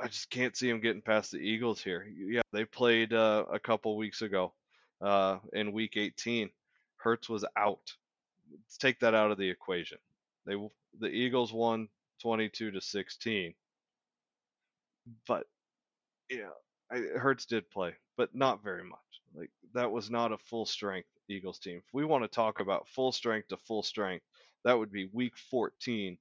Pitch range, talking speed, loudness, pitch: 105-120 Hz, 170 wpm, -33 LUFS, 110 Hz